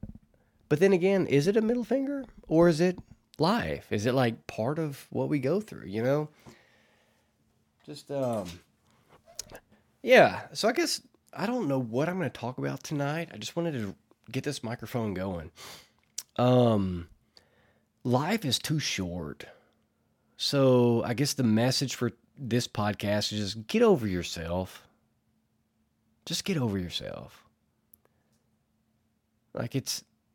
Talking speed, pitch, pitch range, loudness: 140 wpm, 125 Hz, 105-150 Hz, -28 LUFS